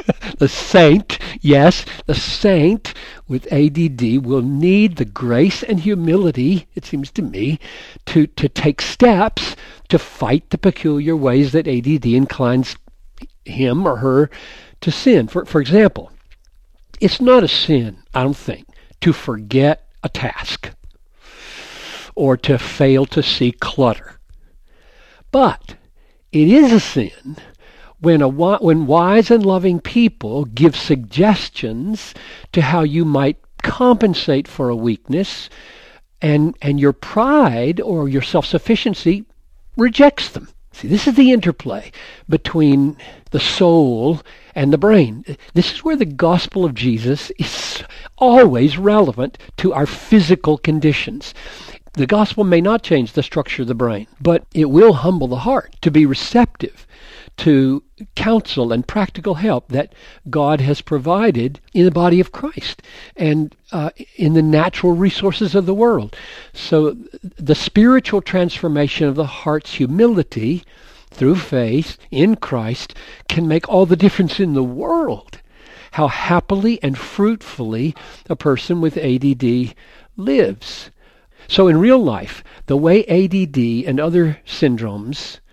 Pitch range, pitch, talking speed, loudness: 140-195 Hz, 160 Hz, 140 wpm, -15 LUFS